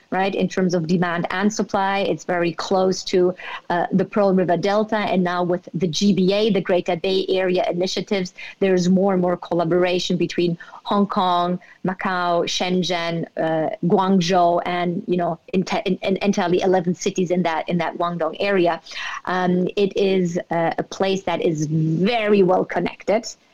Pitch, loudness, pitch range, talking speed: 185 Hz, -20 LUFS, 175-195 Hz, 170 wpm